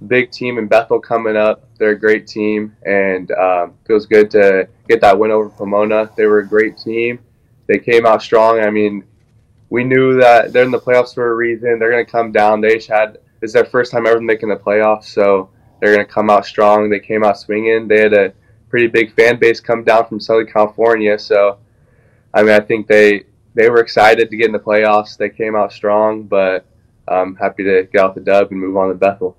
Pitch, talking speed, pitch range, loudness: 110 Hz, 225 wpm, 105-115 Hz, -13 LUFS